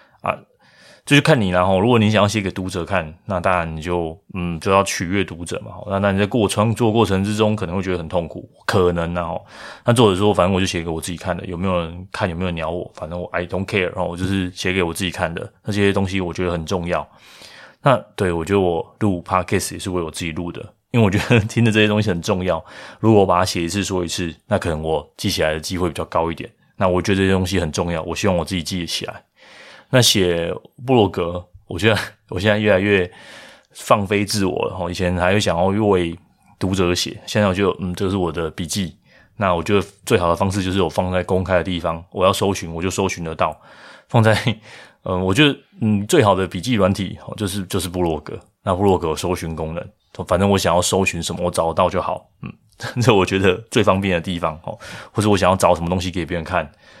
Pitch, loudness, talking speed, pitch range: 95 Hz, -19 LUFS, 350 characters per minute, 90-100 Hz